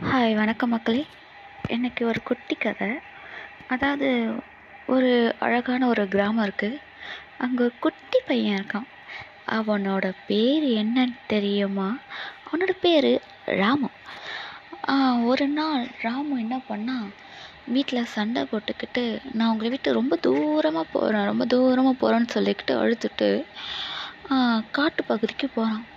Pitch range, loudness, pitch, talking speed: 220-275 Hz, -24 LUFS, 245 Hz, 105 wpm